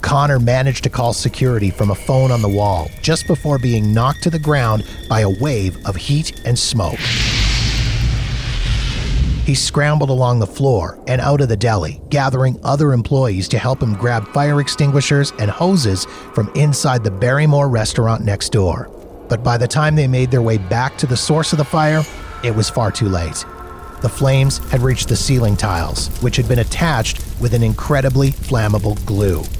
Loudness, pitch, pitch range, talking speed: -16 LUFS, 120 Hz, 110-140 Hz, 180 wpm